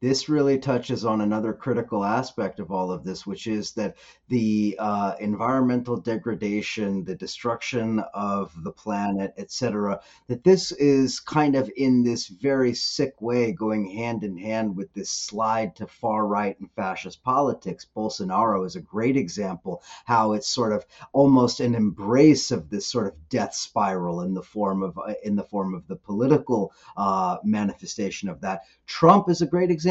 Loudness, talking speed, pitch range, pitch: -24 LUFS, 175 wpm, 100-125 Hz, 110 Hz